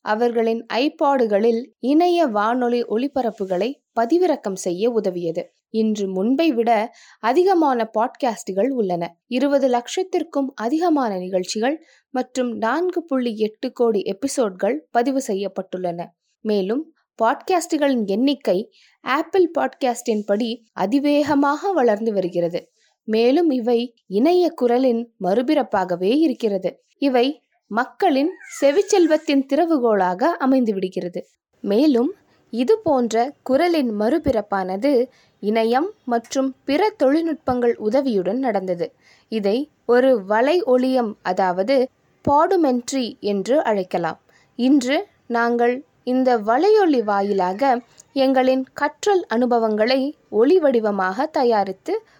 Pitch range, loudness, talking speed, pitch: 215-285 Hz, -20 LUFS, 85 wpm, 245 Hz